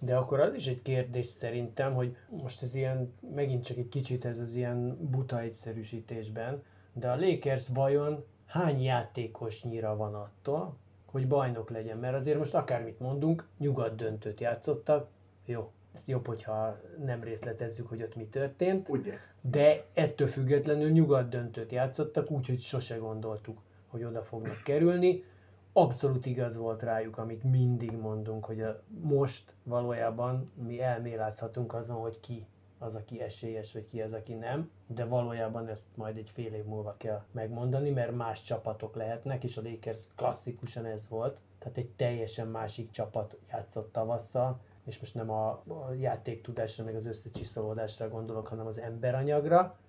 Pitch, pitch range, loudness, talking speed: 120 Hz, 110-130 Hz, -34 LUFS, 150 wpm